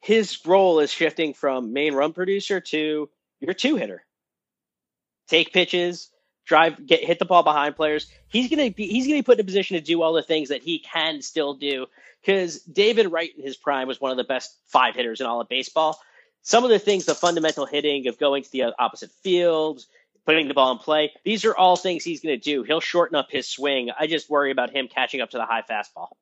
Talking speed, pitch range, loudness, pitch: 225 wpm, 145-185 Hz, -22 LUFS, 160 Hz